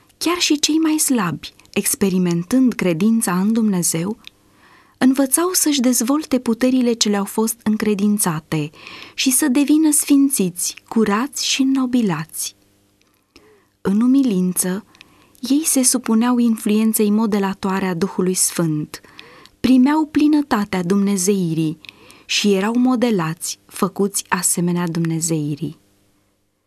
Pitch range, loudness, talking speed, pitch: 180-255 Hz, -18 LUFS, 95 wpm, 210 Hz